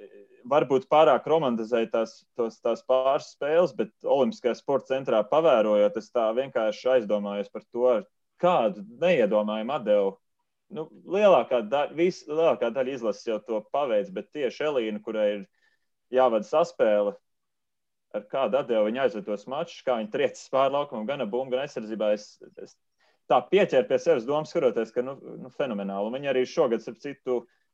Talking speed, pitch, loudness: 140 wpm, 130 Hz, -26 LUFS